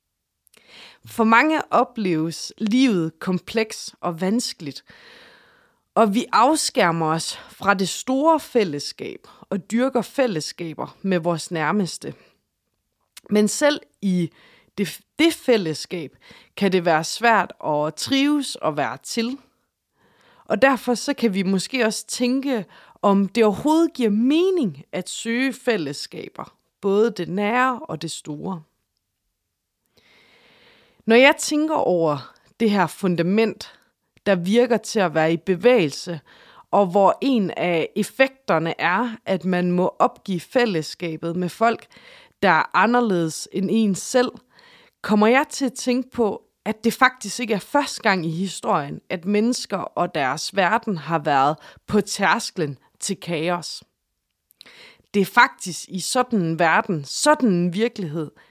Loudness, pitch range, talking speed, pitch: -21 LUFS, 175-245 Hz, 130 wpm, 200 Hz